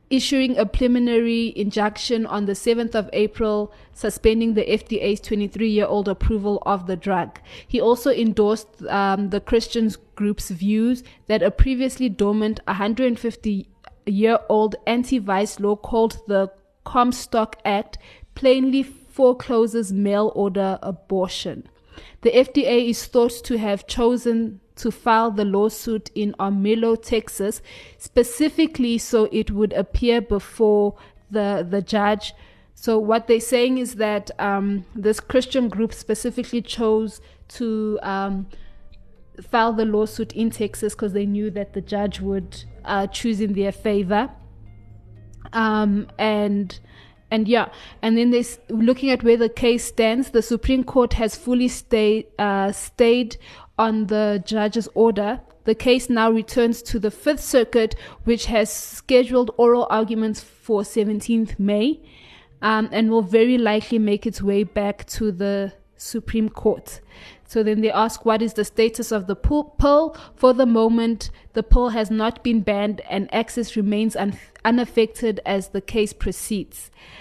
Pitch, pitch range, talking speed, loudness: 220 Hz, 205-235 Hz, 140 wpm, -21 LUFS